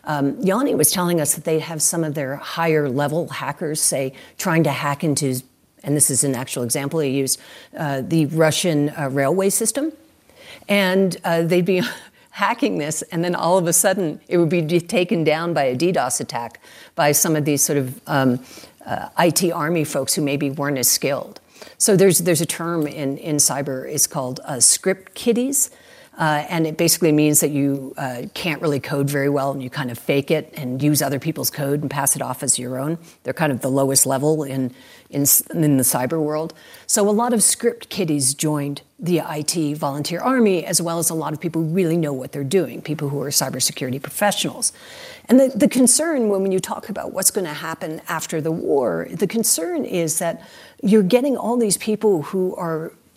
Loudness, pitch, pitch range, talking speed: -19 LUFS, 160 Hz, 140-180 Hz, 205 wpm